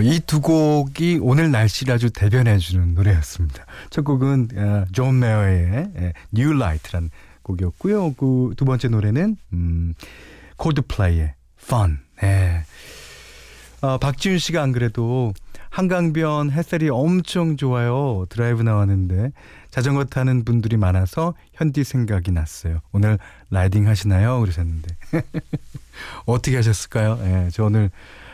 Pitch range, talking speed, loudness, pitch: 95-140 Hz, 285 characters per minute, -20 LUFS, 115 Hz